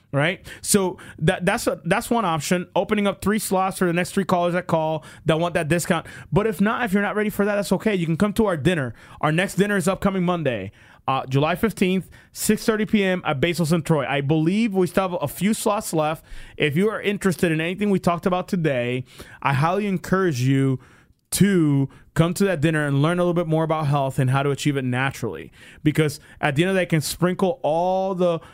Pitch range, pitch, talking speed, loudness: 150-195 Hz, 175 Hz, 230 wpm, -22 LUFS